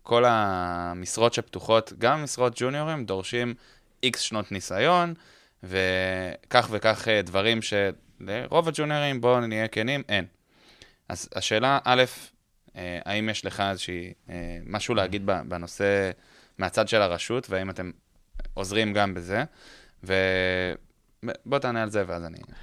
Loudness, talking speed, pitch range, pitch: -26 LUFS, 115 wpm, 95-120 Hz, 105 Hz